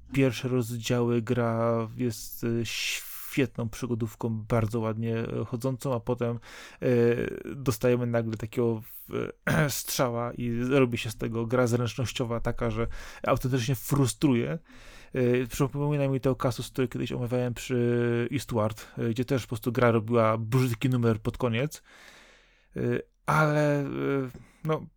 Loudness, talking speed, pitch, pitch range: -28 LUFS, 115 wpm, 120 Hz, 115-130 Hz